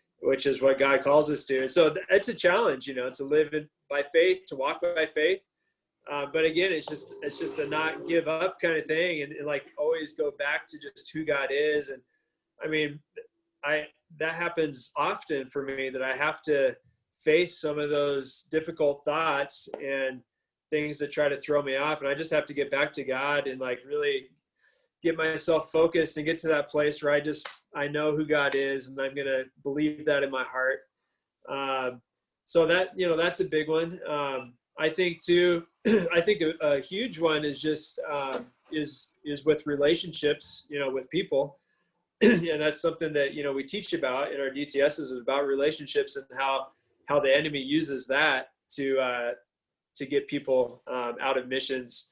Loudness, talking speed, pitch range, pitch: -28 LUFS, 200 wpm, 135-170 Hz, 150 Hz